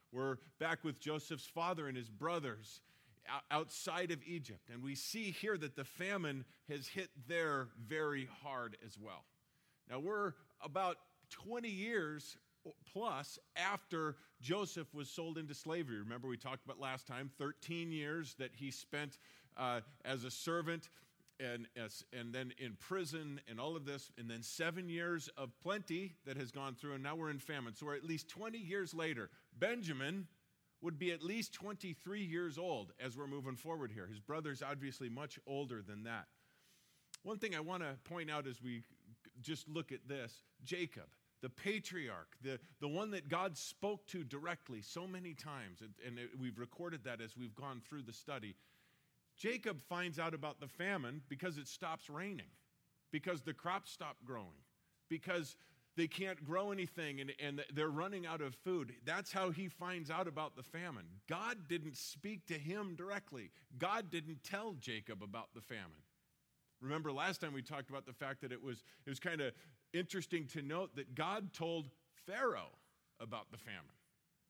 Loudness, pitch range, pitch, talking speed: -45 LUFS, 130-175 Hz, 150 Hz, 175 wpm